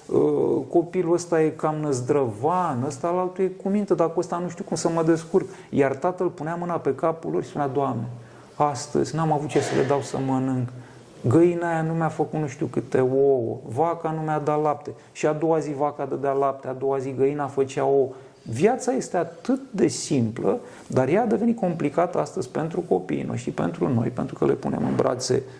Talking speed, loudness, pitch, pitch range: 205 wpm, -24 LUFS, 150 Hz, 135-170 Hz